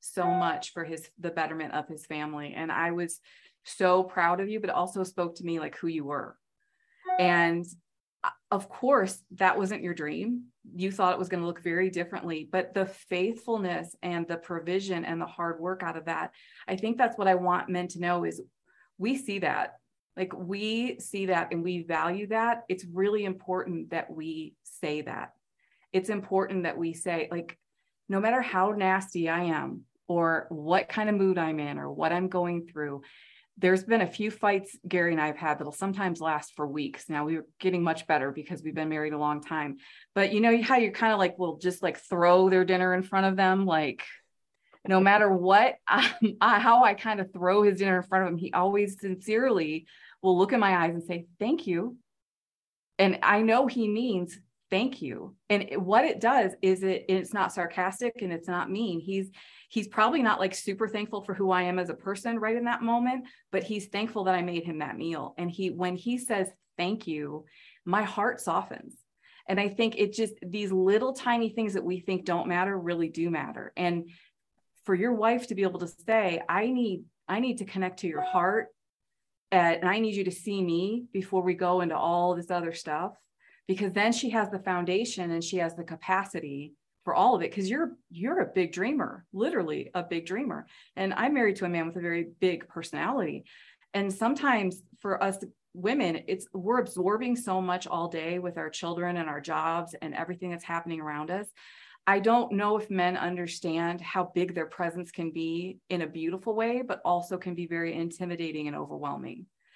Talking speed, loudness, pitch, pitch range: 205 wpm, -29 LUFS, 185 Hz, 170-205 Hz